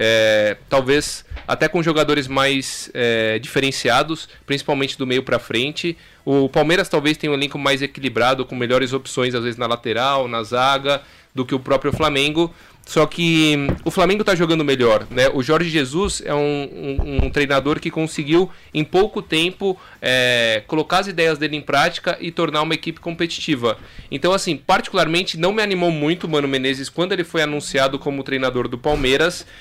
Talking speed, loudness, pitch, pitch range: 175 wpm, -19 LUFS, 145 Hz, 135-165 Hz